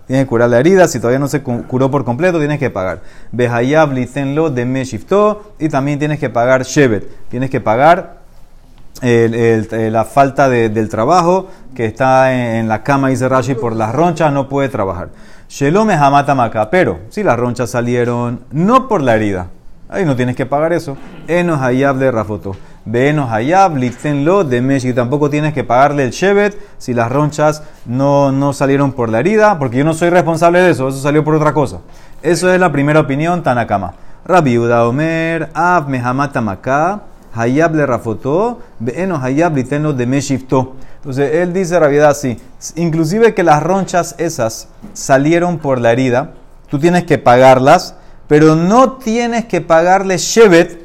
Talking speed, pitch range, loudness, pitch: 150 wpm, 120-165 Hz, -13 LUFS, 140 Hz